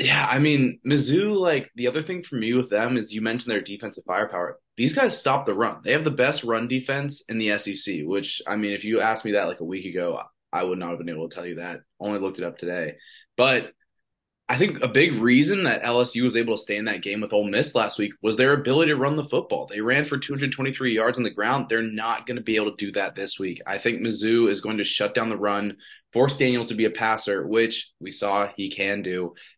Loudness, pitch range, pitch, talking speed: -24 LUFS, 100-125 Hz, 115 Hz, 260 wpm